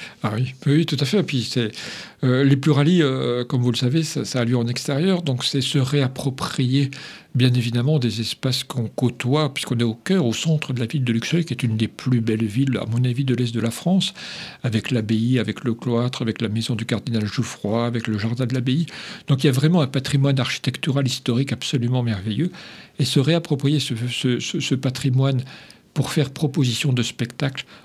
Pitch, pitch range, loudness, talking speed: 130 Hz, 120-145 Hz, -21 LUFS, 215 wpm